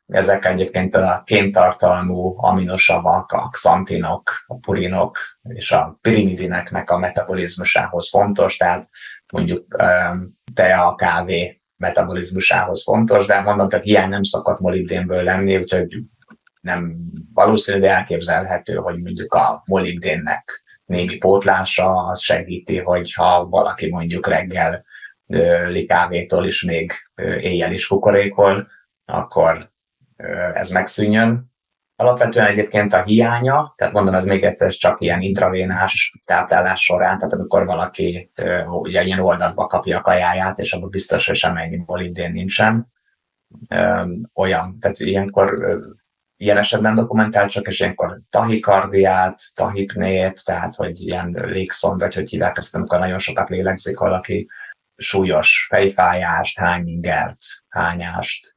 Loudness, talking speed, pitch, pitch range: -17 LUFS, 115 wpm, 95 Hz, 90-100 Hz